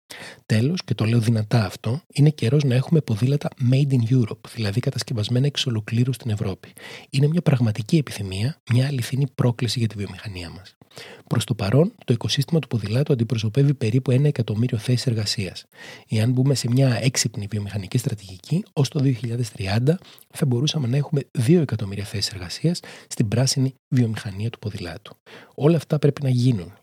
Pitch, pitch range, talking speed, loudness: 125 Hz, 110-140 Hz, 160 wpm, -22 LUFS